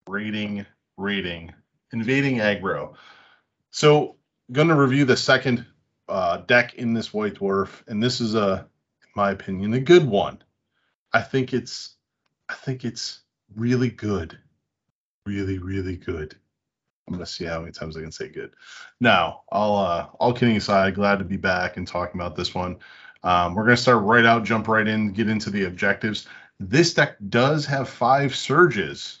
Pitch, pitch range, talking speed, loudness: 105 Hz, 95-125 Hz, 165 wpm, -22 LUFS